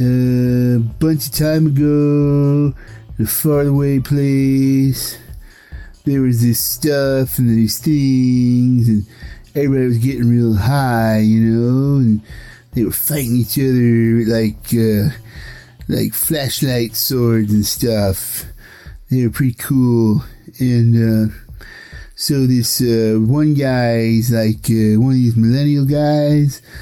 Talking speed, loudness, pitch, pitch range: 130 wpm, -15 LUFS, 125 Hz, 115-140 Hz